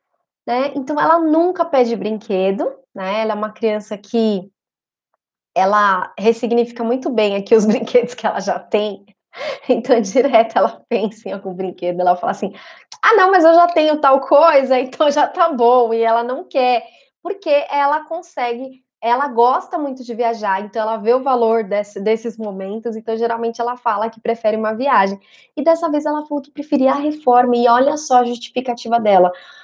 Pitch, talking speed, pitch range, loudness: 240 Hz, 180 wpm, 220-280 Hz, -17 LUFS